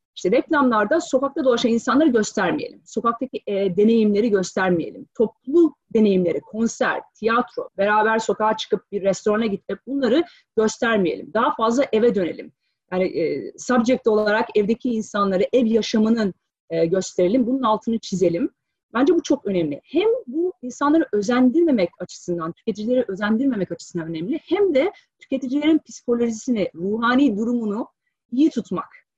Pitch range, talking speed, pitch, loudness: 205-270 Hz, 125 wpm, 230 Hz, -21 LUFS